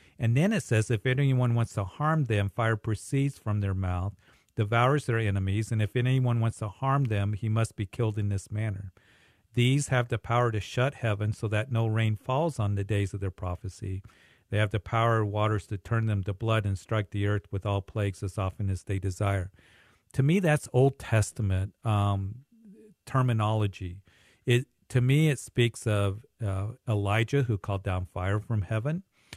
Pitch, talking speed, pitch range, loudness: 110 Hz, 190 wpm, 100-120 Hz, -28 LUFS